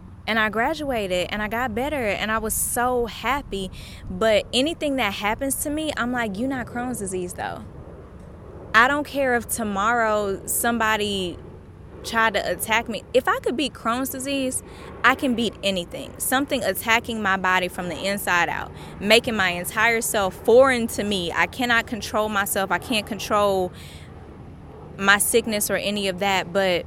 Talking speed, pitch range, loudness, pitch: 165 wpm, 195-245 Hz, -22 LUFS, 220 Hz